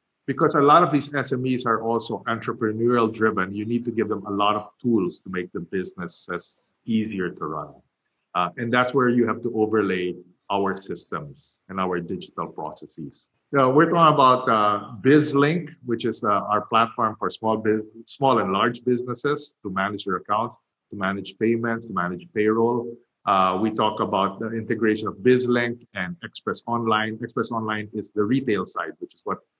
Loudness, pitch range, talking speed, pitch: -23 LUFS, 105-120 Hz, 185 wpm, 115 Hz